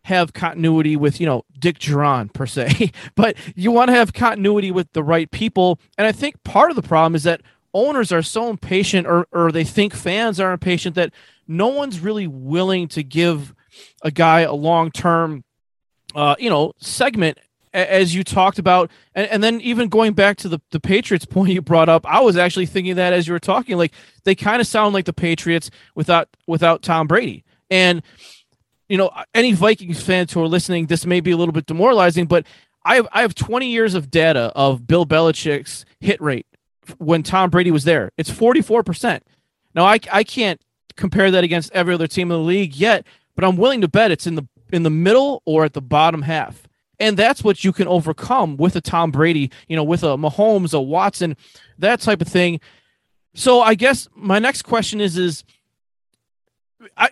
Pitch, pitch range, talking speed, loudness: 175 Hz, 160-200 Hz, 200 wpm, -17 LUFS